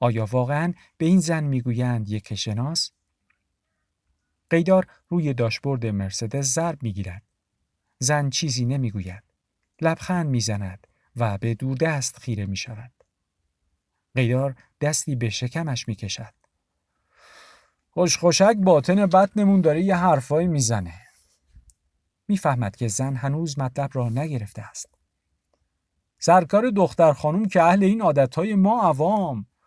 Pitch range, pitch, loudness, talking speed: 105-165 Hz, 130 Hz, -22 LUFS, 115 wpm